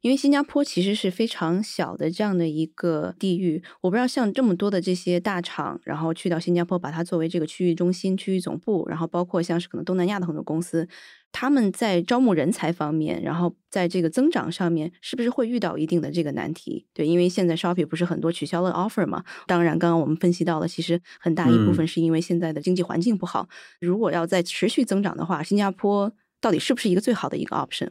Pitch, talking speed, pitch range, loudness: 175 Hz, 395 characters per minute, 165-195 Hz, -24 LUFS